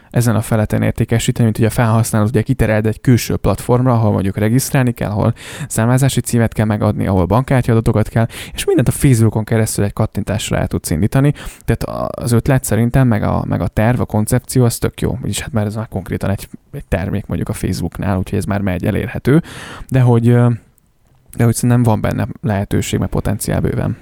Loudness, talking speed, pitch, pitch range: -16 LUFS, 190 wpm, 110 Hz, 105-120 Hz